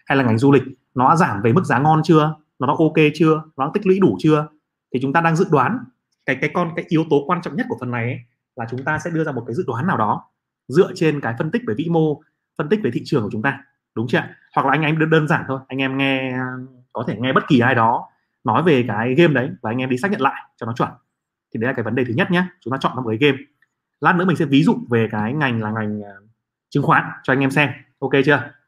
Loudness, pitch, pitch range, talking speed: -19 LUFS, 145 Hz, 130-160 Hz, 290 wpm